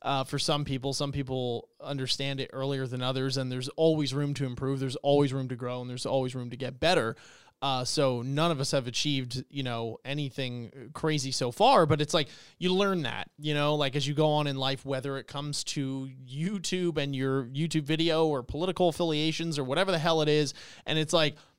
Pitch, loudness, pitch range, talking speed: 140 Hz, -29 LUFS, 135-155 Hz, 215 wpm